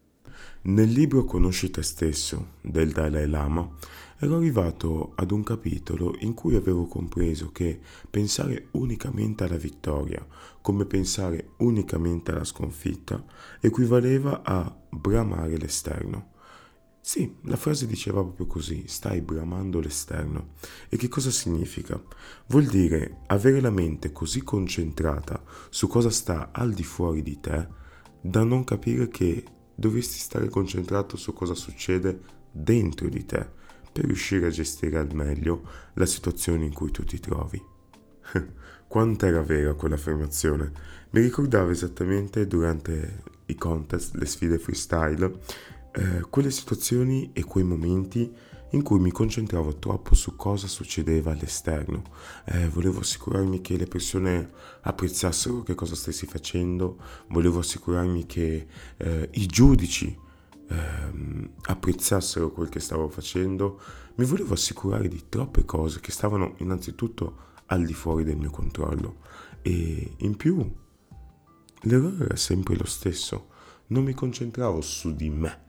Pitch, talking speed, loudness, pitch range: 90 Hz, 130 wpm, -27 LUFS, 80-105 Hz